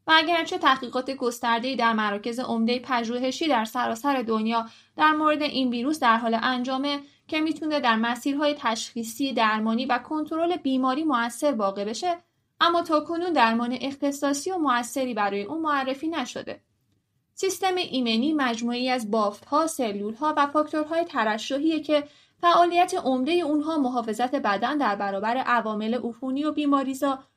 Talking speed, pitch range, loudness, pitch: 135 wpm, 235-305 Hz, -25 LUFS, 265 Hz